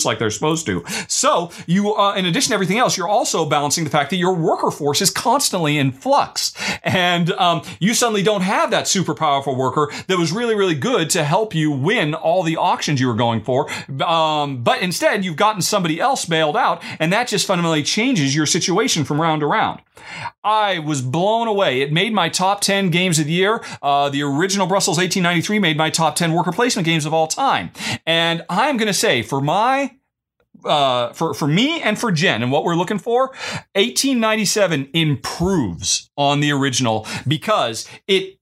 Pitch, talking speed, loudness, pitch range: 175 Hz, 205 wpm, -18 LUFS, 150-205 Hz